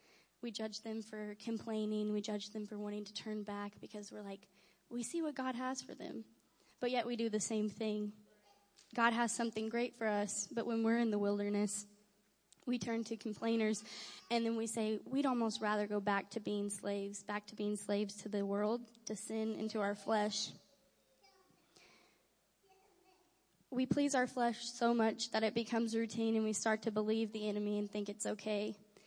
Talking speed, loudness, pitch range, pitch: 190 wpm, -39 LUFS, 210-230 Hz, 215 Hz